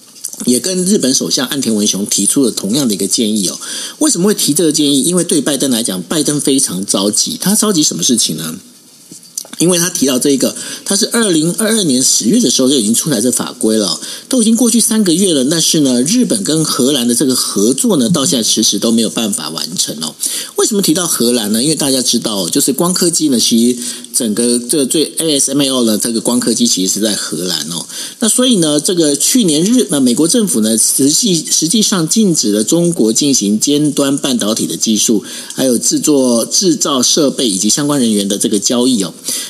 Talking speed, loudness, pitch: 325 characters per minute, -12 LUFS, 145 Hz